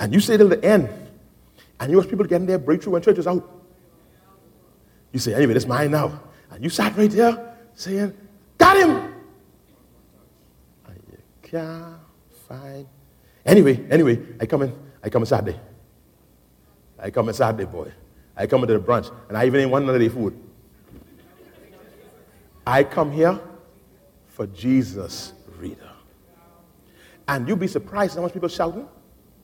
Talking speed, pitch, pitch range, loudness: 155 wpm, 150 Hz, 120-185 Hz, -20 LUFS